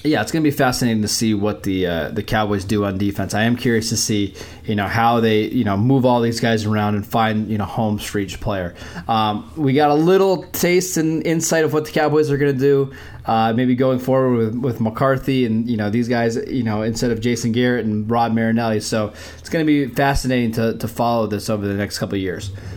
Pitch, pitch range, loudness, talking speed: 115 Hz, 105-130 Hz, -19 LUFS, 250 wpm